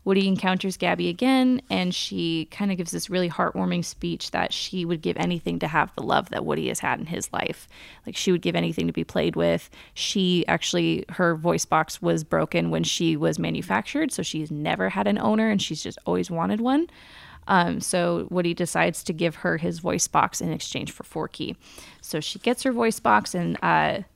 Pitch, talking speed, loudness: 175 Hz, 210 wpm, -25 LUFS